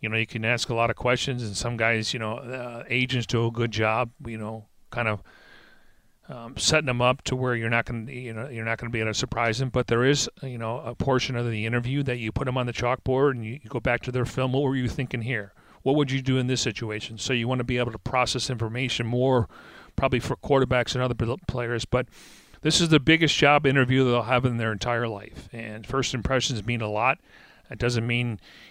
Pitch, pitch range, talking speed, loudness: 120 Hz, 115-130 Hz, 245 wpm, -25 LUFS